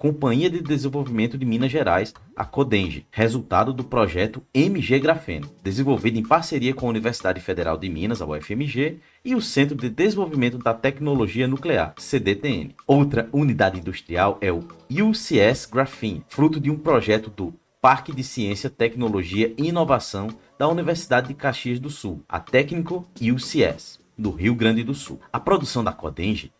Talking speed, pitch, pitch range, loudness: 155 wpm, 130 Hz, 110-145 Hz, -22 LUFS